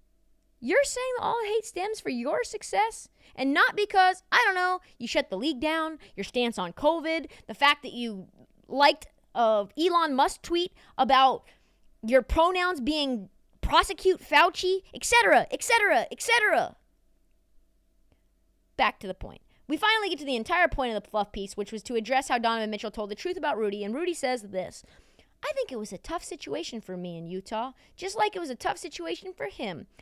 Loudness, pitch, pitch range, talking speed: -26 LUFS, 295 Hz, 225-365 Hz, 180 wpm